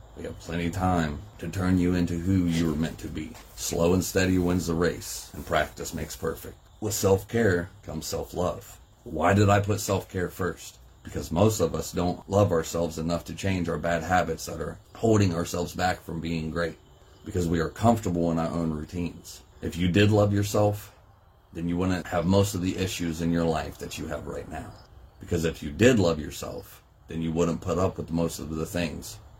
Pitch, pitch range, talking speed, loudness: 90 Hz, 85-95 Hz, 210 wpm, -27 LUFS